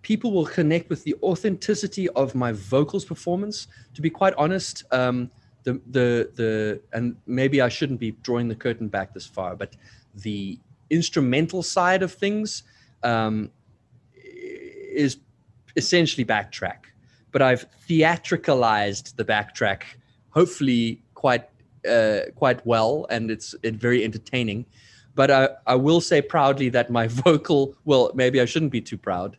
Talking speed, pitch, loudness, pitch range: 145 wpm, 125 Hz, -23 LUFS, 115-160 Hz